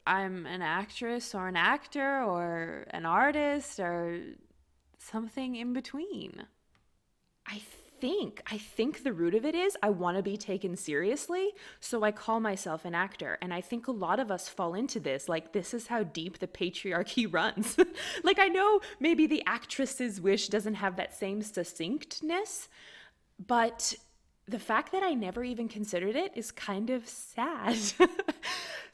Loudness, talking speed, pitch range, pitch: -32 LUFS, 160 wpm, 190-280 Hz, 225 Hz